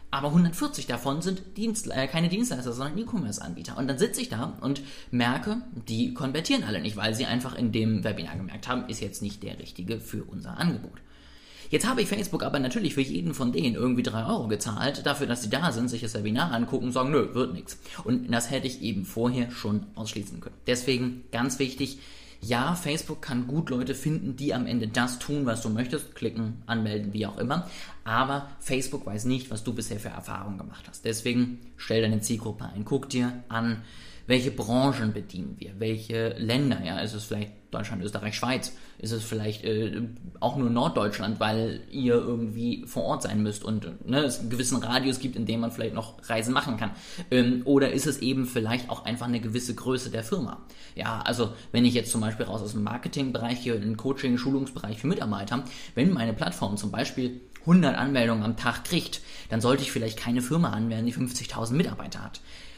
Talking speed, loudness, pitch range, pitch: 200 wpm, -28 LUFS, 110-135 Hz, 120 Hz